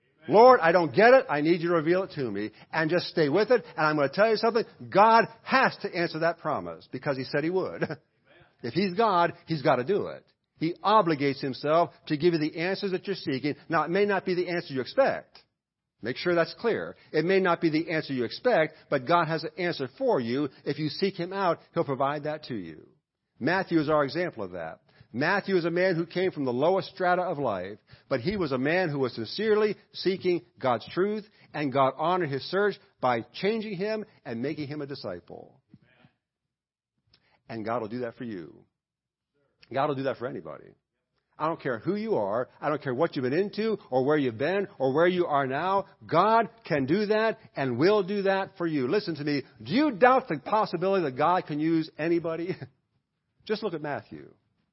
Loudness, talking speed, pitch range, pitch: -27 LUFS, 215 wpm, 145-190 Hz, 165 Hz